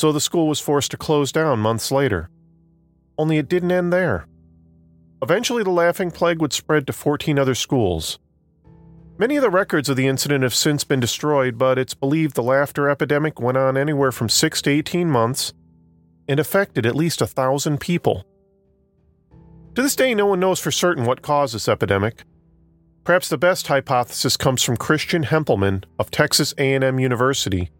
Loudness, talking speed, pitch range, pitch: -19 LUFS, 175 wpm, 115-160 Hz, 140 Hz